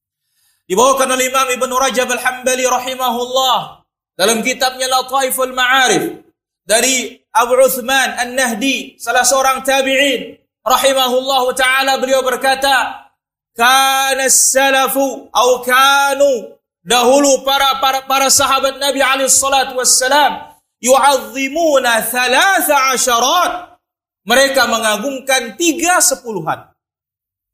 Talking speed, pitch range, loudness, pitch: 90 wpm, 255-270 Hz, -13 LUFS, 265 Hz